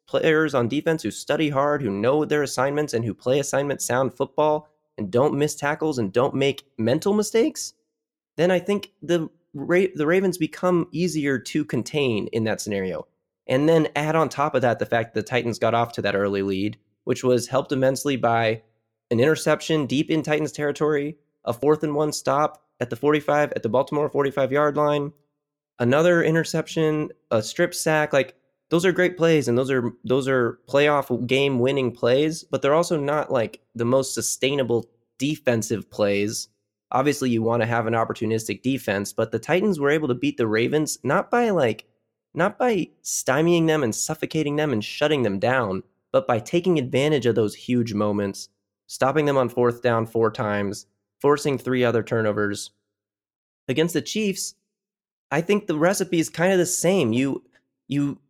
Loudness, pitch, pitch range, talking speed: -23 LUFS, 140 Hz, 115-155 Hz, 180 wpm